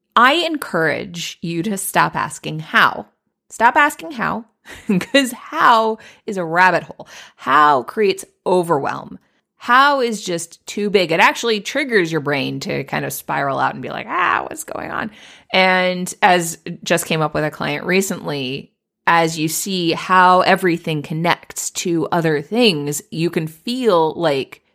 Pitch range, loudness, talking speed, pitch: 165-225 Hz, -17 LUFS, 155 wpm, 185 Hz